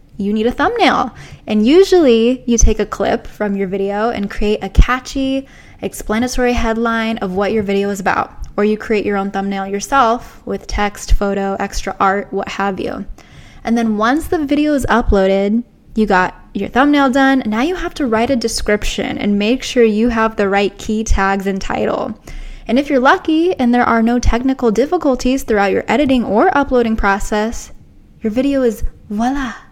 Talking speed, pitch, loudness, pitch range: 180 wpm, 225 Hz, -15 LUFS, 200-260 Hz